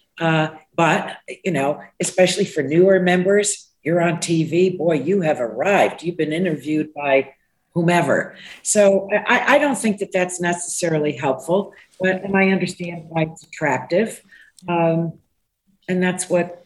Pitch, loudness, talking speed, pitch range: 175 Hz, -19 LUFS, 145 wpm, 160-185 Hz